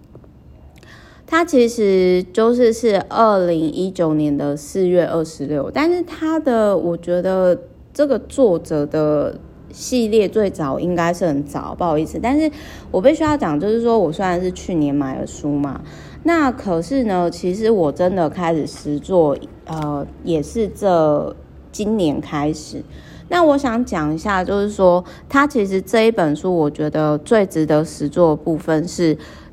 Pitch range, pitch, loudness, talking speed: 155-225 Hz, 180 Hz, -18 LUFS, 225 characters per minute